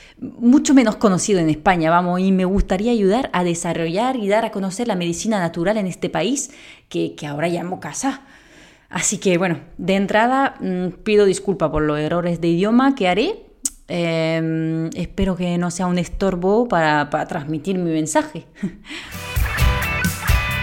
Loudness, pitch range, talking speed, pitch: -19 LUFS, 170-215 Hz, 155 wpm, 185 Hz